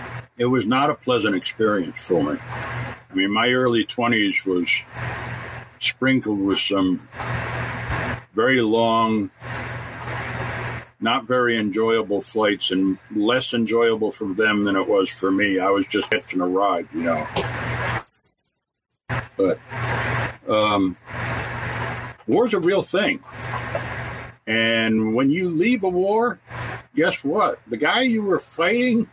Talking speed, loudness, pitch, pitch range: 125 wpm, -22 LUFS, 115 Hz, 105-125 Hz